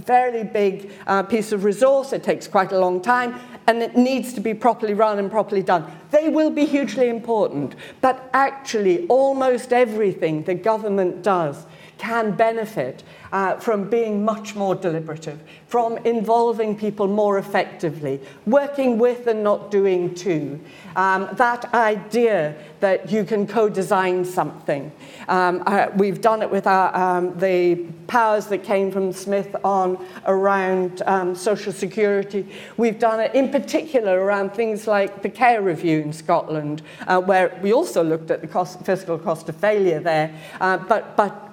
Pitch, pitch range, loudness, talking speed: 200 Hz, 185-230 Hz, -20 LUFS, 160 wpm